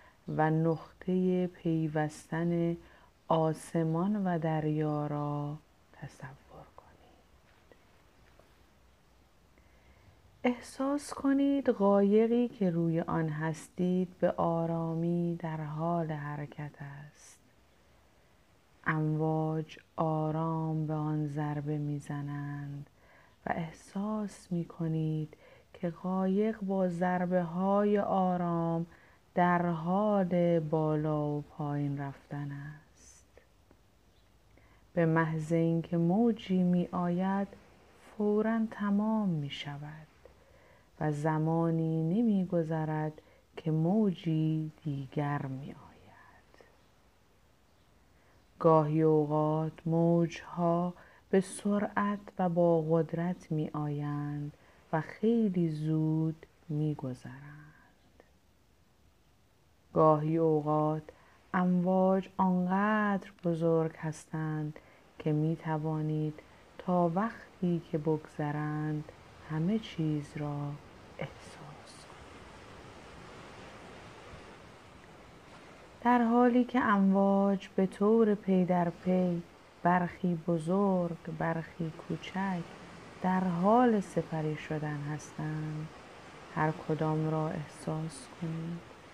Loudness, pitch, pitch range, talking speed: -32 LUFS, 165 Hz, 155-185 Hz, 80 wpm